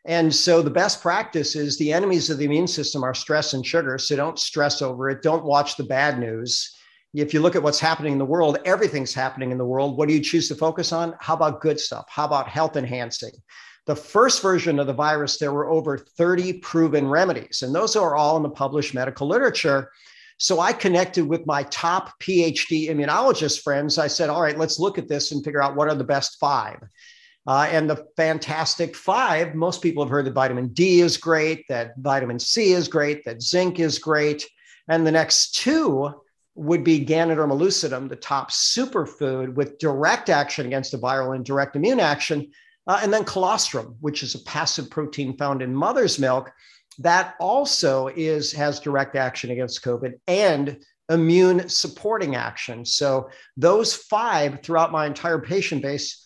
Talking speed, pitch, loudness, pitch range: 190 wpm, 150 Hz, -21 LUFS, 140-165 Hz